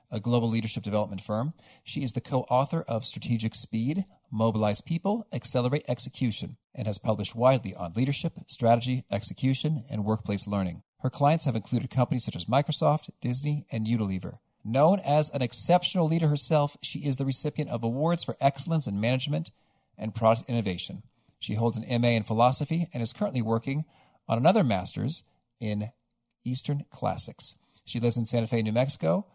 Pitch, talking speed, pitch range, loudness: 125 Hz, 165 wpm, 115-145 Hz, -28 LUFS